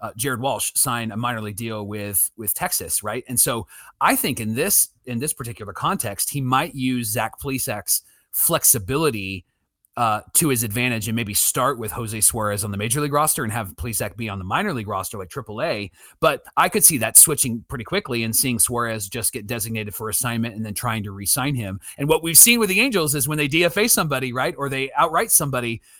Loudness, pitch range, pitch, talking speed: -19 LUFS, 110-135 Hz, 120 Hz, 215 wpm